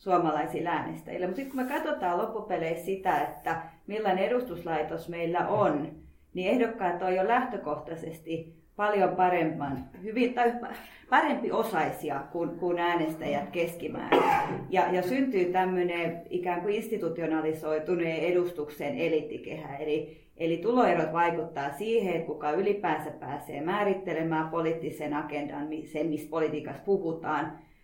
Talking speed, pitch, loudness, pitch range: 115 wpm, 170 Hz, -30 LUFS, 155-195 Hz